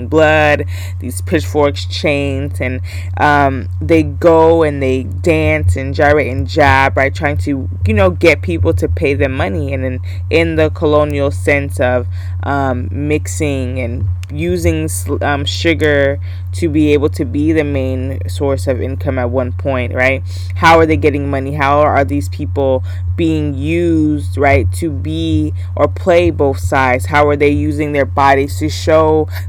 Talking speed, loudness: 160 wpm, -14 LUFS